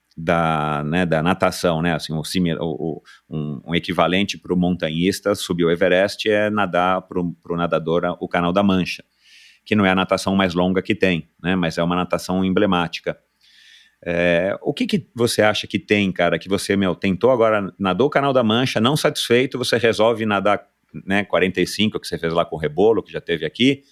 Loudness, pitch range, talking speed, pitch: -20 LUFS, 85-105 Hz, 195 wpm, 90 Hz